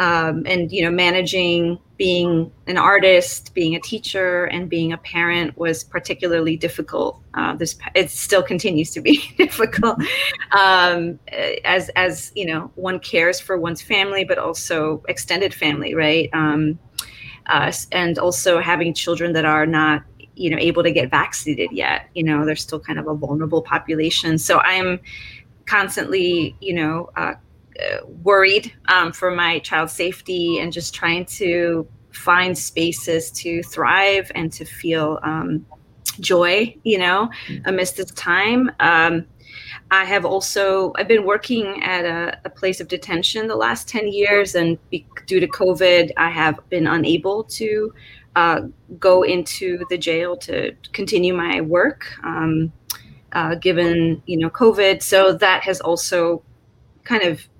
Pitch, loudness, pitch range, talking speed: 175 Hz, -18 LUFS, 160-185 Hz, 150 wpm